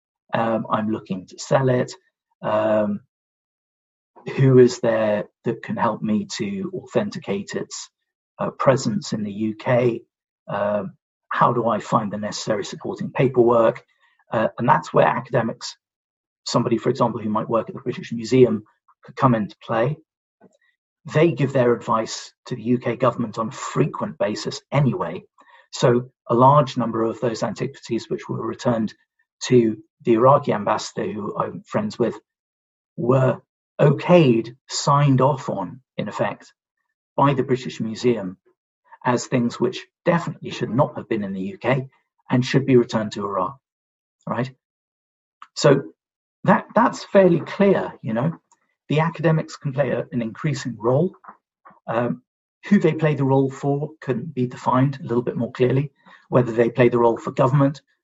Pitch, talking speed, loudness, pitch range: 130 Hz, 150 wpm, -21 LUFS, 115-160 Hz